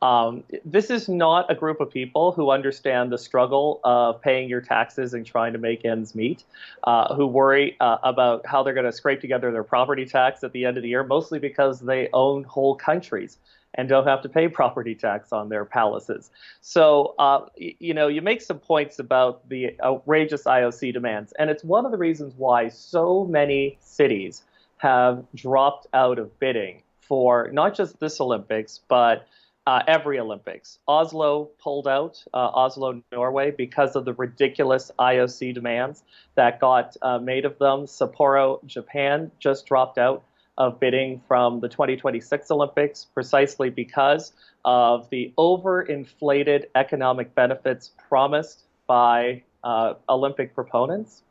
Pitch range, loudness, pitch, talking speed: 125-145 Hz, -22 LUFS, 135 Hz, 160 wpm